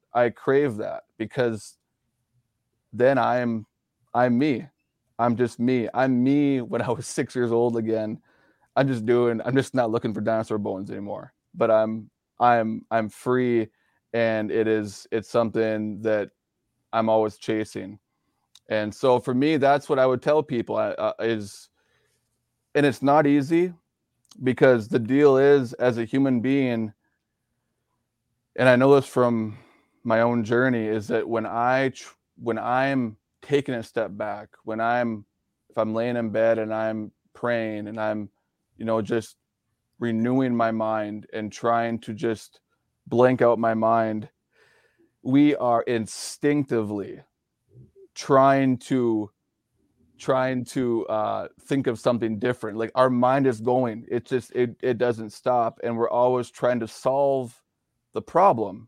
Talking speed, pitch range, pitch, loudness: 150 wpm, 110-130 Hz, 120 Hz, -24 LUFS